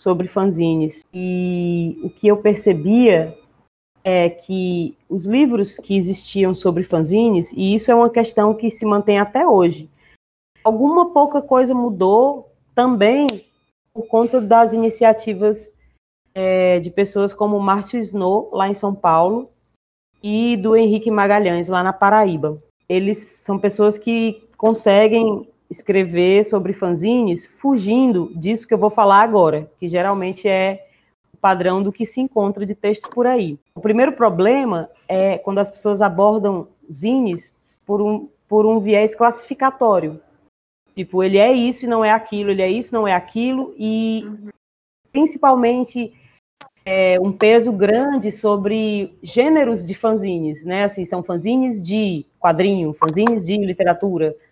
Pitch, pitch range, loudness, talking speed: 205 Hz, 185-225 Hz, -17 LUFS, 140 wpm